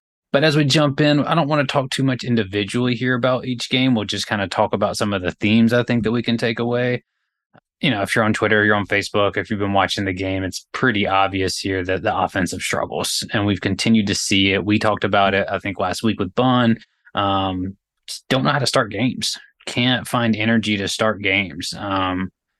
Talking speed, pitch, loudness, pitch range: 230 wpm, 105 Hz, -19 LUFS, 95-120 Hz